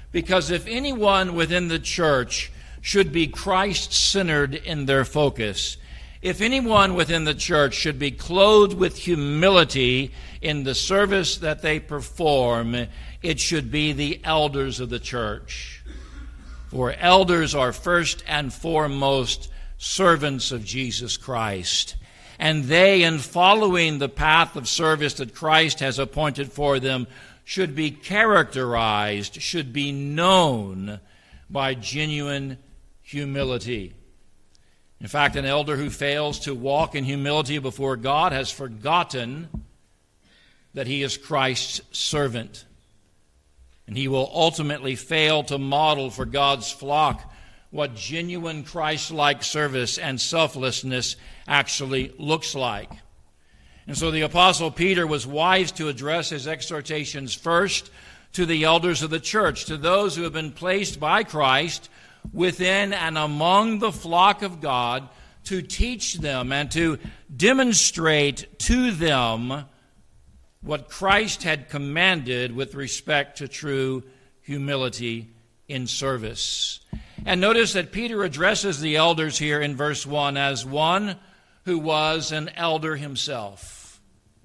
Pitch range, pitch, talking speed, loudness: 130-165 Hz, 145 Hz, 125 wpm, -22 LUFS